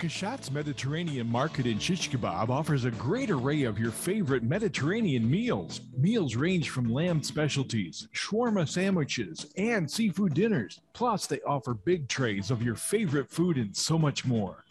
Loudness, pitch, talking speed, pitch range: -29 LUFS, 145 Hz, 150 wpm, 125-175 Hz